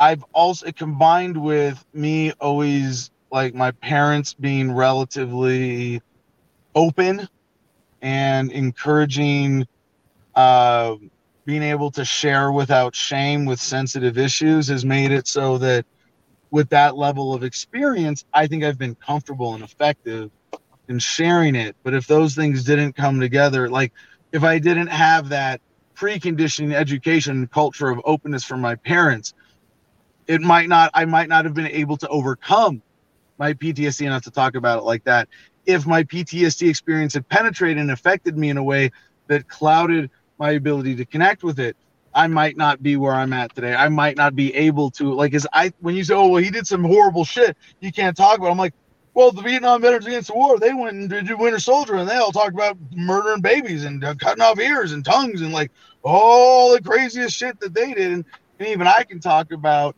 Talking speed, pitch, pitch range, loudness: 180 wpm, 150 Hz, 135-170 Hz, -18 LUFS